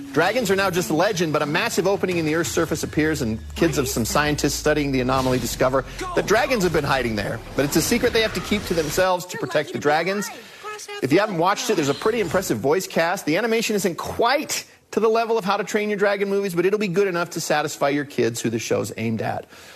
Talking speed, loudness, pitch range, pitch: 250 wpm, -22 LUFS, 140-205 Hz, 170 Hz